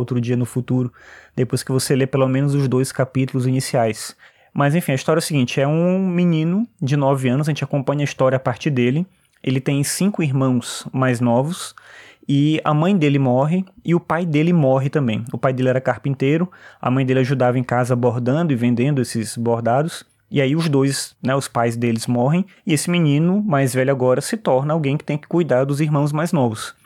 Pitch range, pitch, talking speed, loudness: 125-155 Hz, 135 Hz, 210 wpm, -19 LUFS